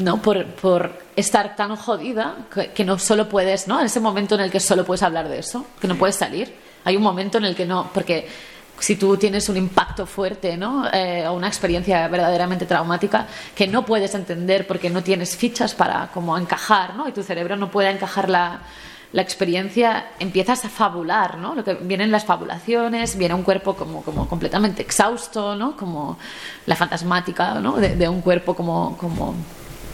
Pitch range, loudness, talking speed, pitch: 180-210 Hz, -21 LUFS, 190 wpm, 195 Hz